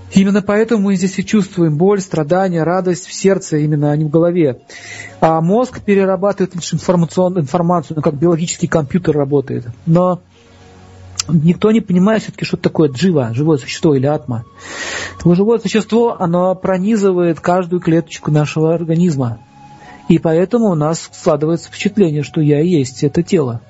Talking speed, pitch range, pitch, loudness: 150 wpm, 150-190 Hz, 170 Hz, -15 LUFS